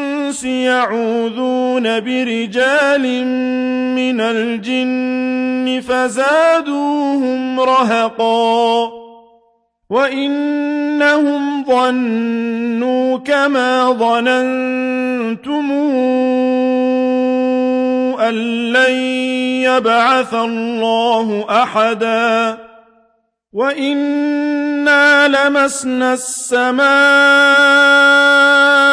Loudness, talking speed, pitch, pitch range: -14 LUFS, 35 wpm, 255 Hz, 230-280 Hz